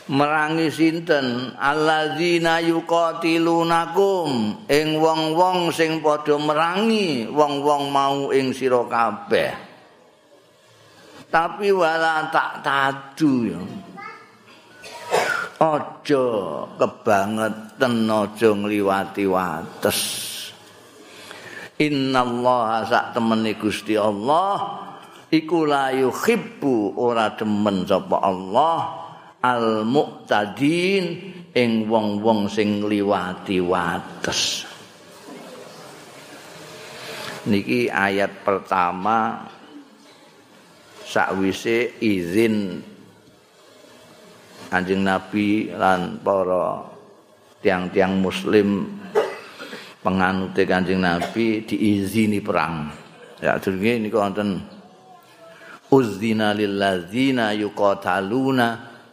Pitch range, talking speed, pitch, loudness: 100-150 Hz, 65 wpm, 115 Hz, -21 LUFS